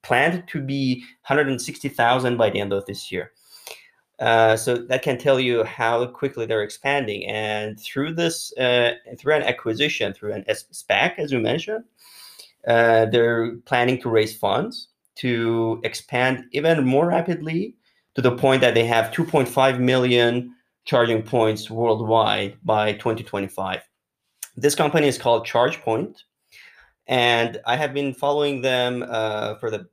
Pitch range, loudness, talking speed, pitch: 110-140 Hz, -21 LUFS, 140 wpm, 120 Hz